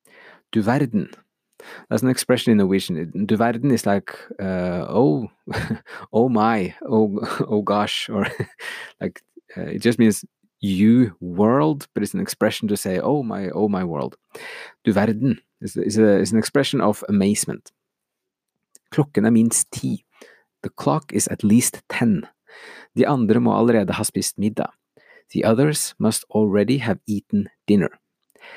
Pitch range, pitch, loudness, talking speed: 105-125 Hz, 110 Hz, -21 LUFS, 130 wpm